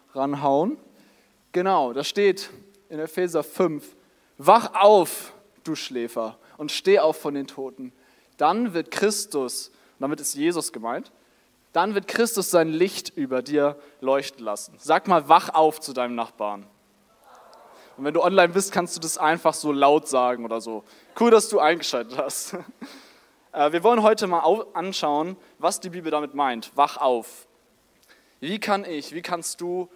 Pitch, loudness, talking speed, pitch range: 160 Hz, -23 LUFS, 155 wpm, 140-185 Hz